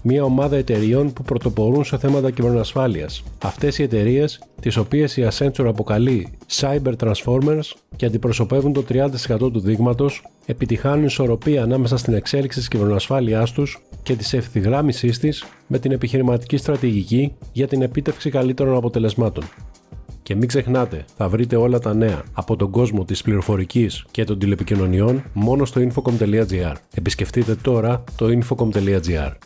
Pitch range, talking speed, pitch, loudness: 110-135 Hz, 140 wpm, 120 Hz, -19 LUFS